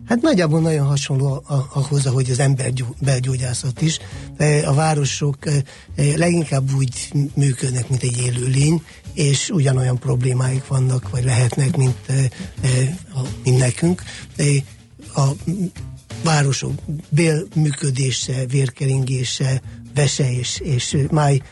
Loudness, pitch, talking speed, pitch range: -19 LUFS, 135 Hz, 110 wpm, 130-145 Hz